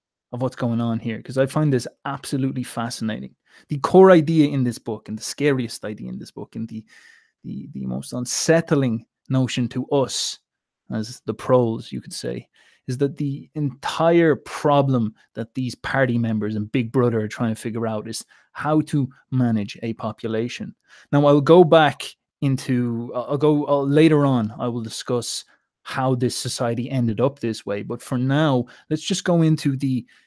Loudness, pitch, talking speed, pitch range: -21 LUFS, 125 Hz, 180 wpm, 115-145 Hz